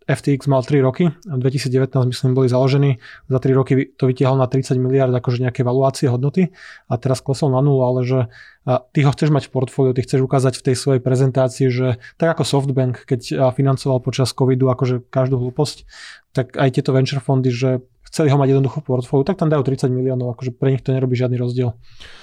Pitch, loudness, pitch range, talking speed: 130 Hz, -18 LUFS, 130-140 Hz, 210 wpm